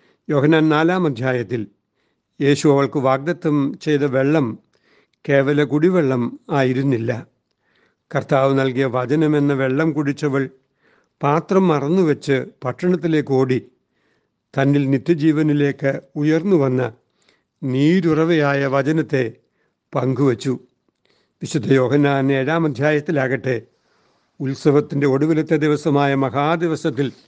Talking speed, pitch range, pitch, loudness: 80 wpm, 135-155 Hz, 140 Hz, -18 LUFS